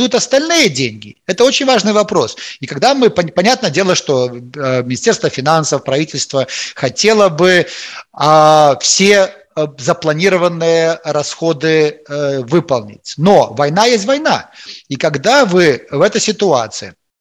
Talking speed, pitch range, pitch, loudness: 110 wpm, 145-205 Hz, 165 Hz, -12 LUFS